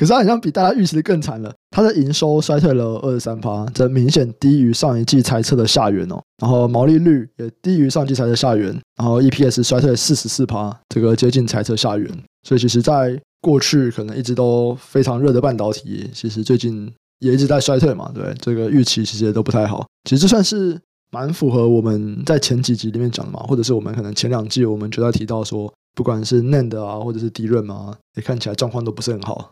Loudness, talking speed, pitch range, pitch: -17 LUFS, 355 characters per minute, 115-140 Hz, 125 Hz